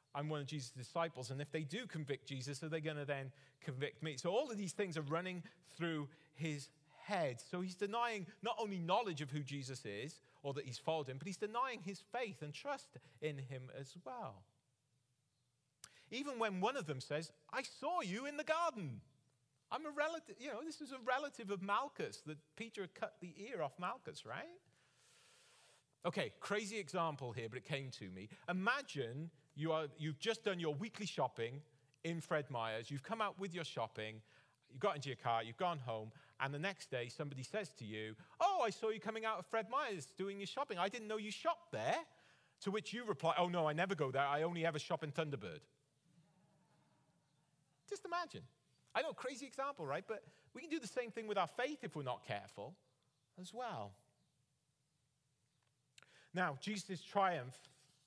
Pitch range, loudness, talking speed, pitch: 140-210 Hz, -43 LUFS, 195 wpm, 160 Hz